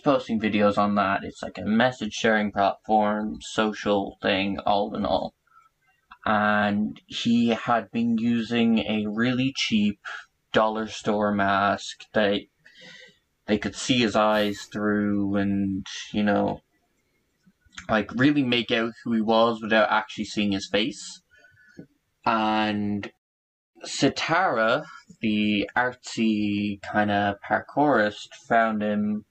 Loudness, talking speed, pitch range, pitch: -24 LUFS, 115 wpm, 105-115 Hz, 105 Hz